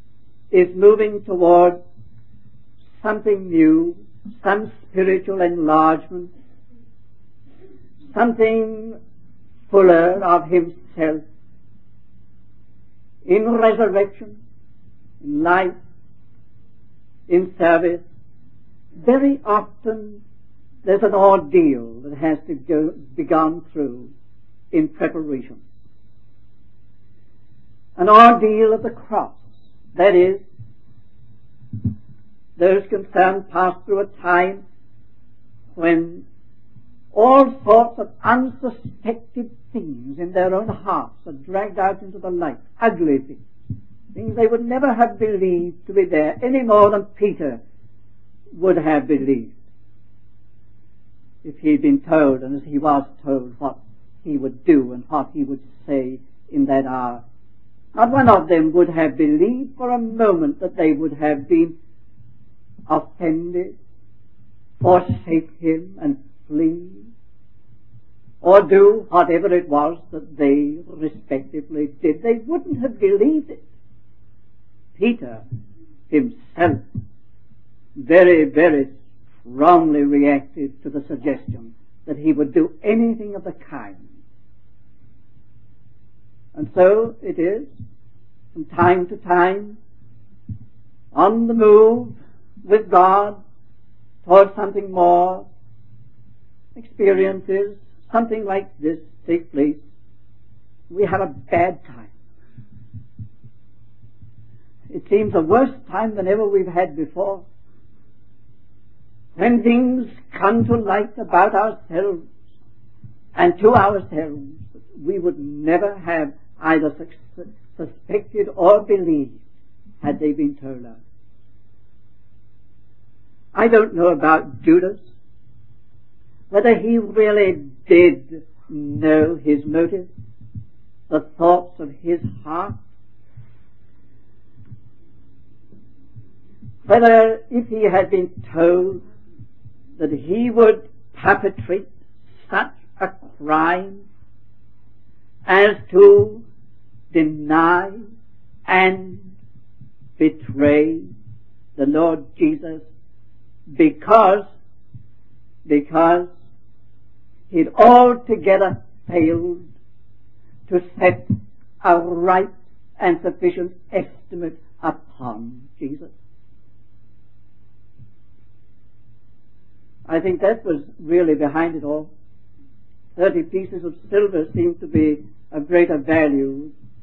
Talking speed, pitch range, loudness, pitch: 95 wpm, 110-190 Hz, -17 LUFS, 145 Hz